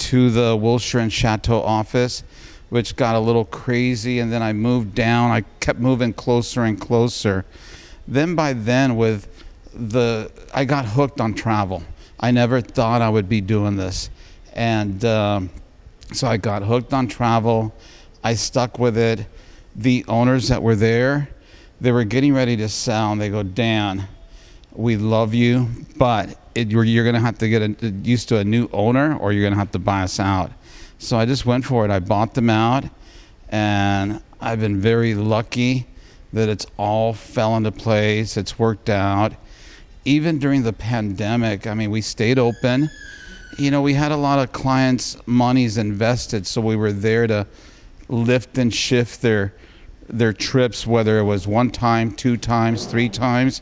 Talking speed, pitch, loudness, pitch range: 175 wpm, 115 Hz, -19 LUFS, 105-125 Hz